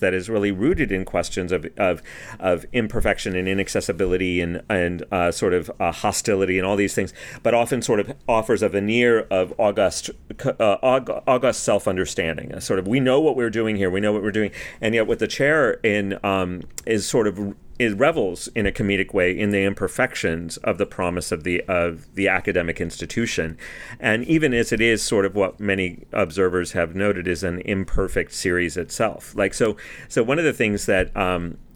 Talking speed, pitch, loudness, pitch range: 195 wpm, 95 Hz, -22 LUFS, 90-105 Hz